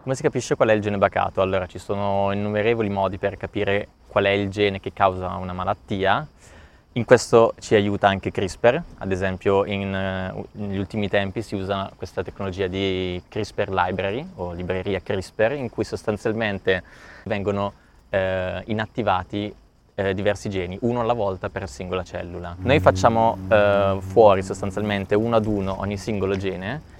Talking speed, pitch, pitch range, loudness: 160 wpm, 100 Hz, 95-105 Hz, -23 LUFS